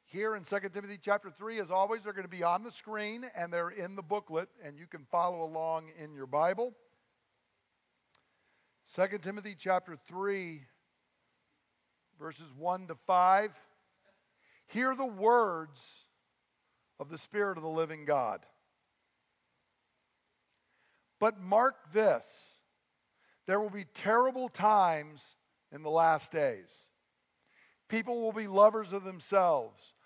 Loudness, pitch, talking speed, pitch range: -32 LUFS, 195 Hz, 130 wpm, 165-215 Hz